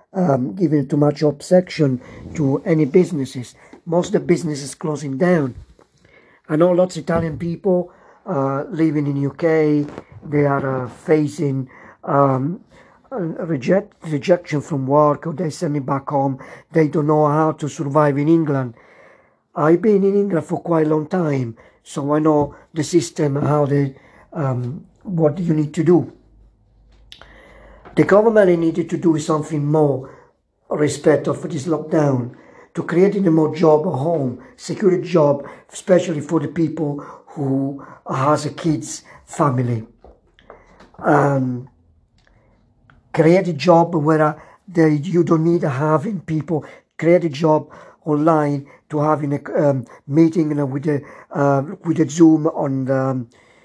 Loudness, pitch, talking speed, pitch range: -18 LUFS, 155 Hz, 145 wpm, 140-170 Hz